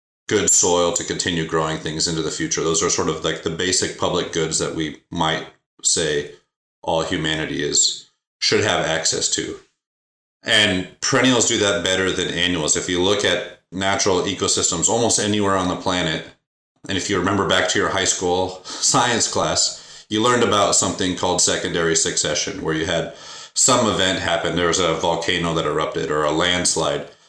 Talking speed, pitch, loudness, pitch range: 175 wpm, 90 Hz, -19 LUFS, 85-105 Hz